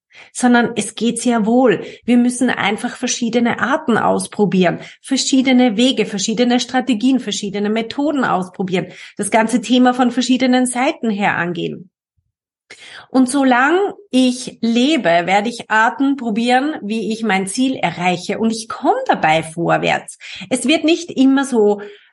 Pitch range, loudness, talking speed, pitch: 205-255 Hz, -16 LUFS, 135 wpm, 235 Hz